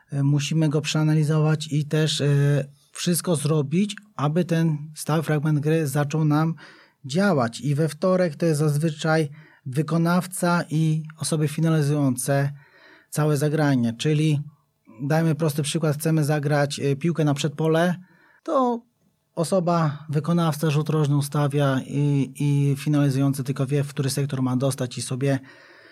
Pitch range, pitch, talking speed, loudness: 145-160 Hz, 155 Hz, 125 wpm, -23 LUFS